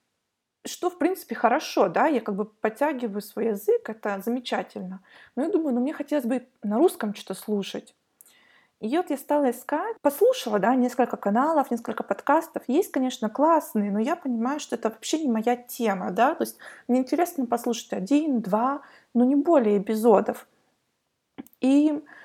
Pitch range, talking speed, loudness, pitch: 225-295 Hz, 160 wpm, -25 LUFS, 250 Hz